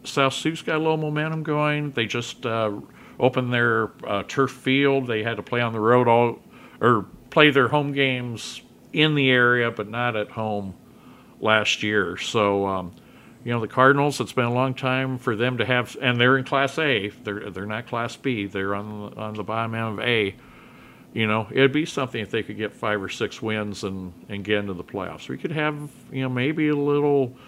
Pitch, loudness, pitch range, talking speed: 120 Hz, -23 LUFS, 110-135 Hz, 210 wpm